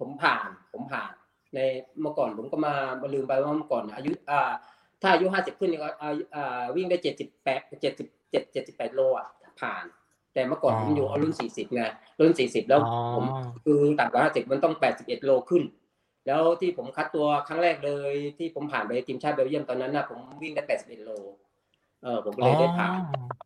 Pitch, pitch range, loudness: 145 Hz, 130-165 Hz, -27 LUFS